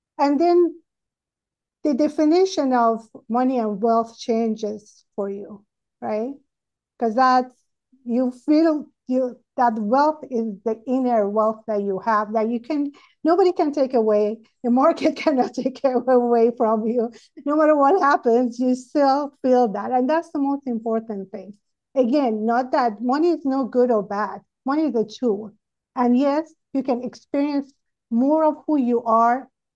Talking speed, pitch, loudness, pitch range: 155 wpm, 250 Hz, -21 LUFS, 225-285 Hz